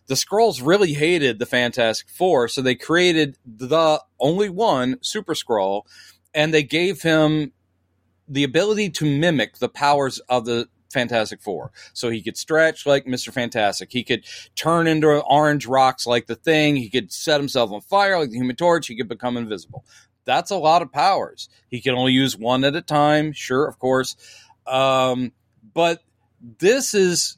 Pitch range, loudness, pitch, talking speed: 120-155 Hz, -20 LUFS, 135 Hz, 175 wpm